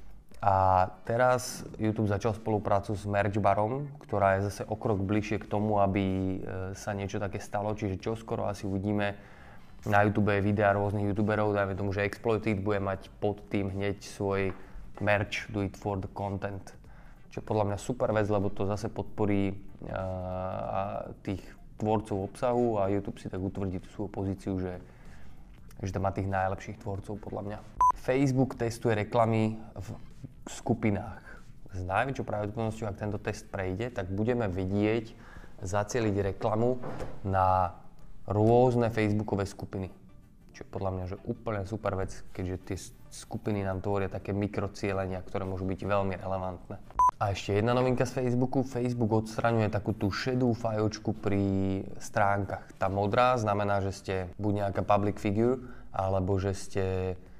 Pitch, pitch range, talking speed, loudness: 100 Hz, 95-110 Hz, 150 wpm, -30 LUFS